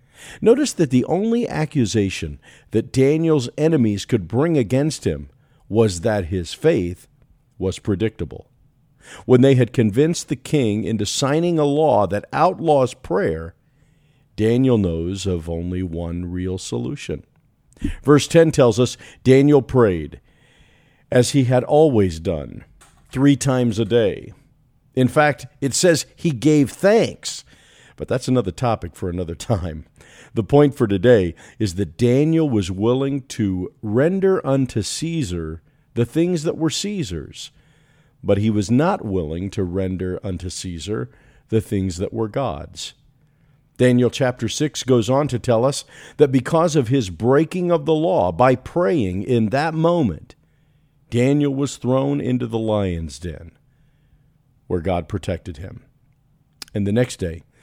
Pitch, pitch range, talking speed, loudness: 125 Hz, 100-145 Hz, 140 wpm, -19 LUFS